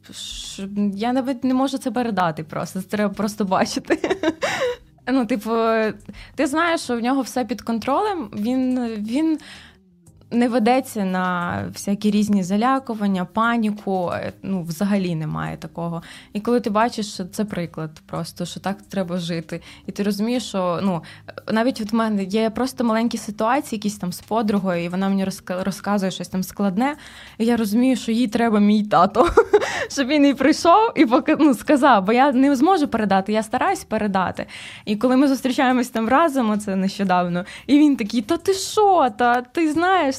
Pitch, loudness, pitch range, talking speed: 225 Hz, -20 LUFS, 195-265 Hz, 165 wpm